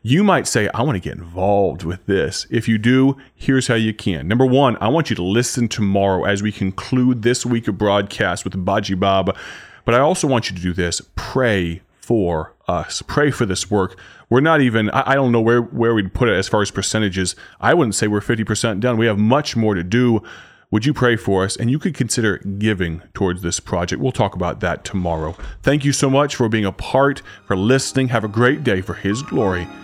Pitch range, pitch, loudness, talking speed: 95-125 Hz, 110 Hz, -18 LUFS, 225 wpm